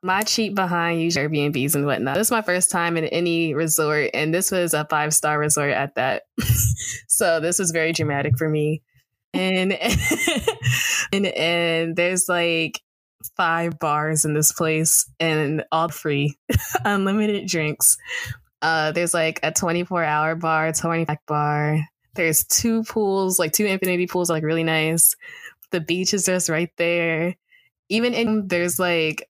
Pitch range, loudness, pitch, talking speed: 155-180 Hz, -20 LUFS, 165 Hz, 160 wpm